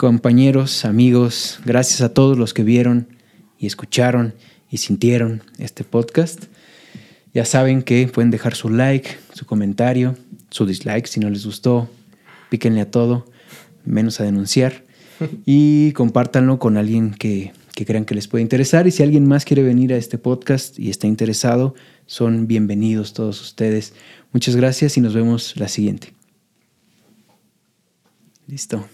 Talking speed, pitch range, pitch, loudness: 145 wpm, 110-130 Hz, 120 Hz, -17 LUFS